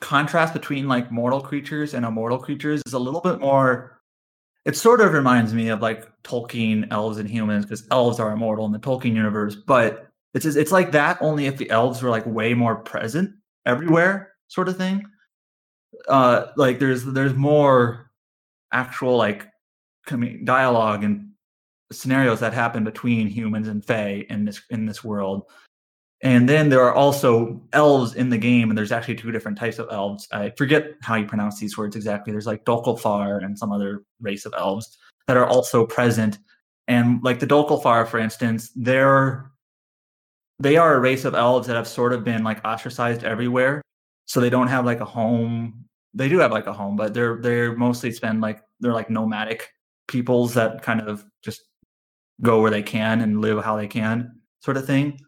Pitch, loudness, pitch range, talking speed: 115 Hz, -21 LUFS, 110-130 Hz, 185 wpm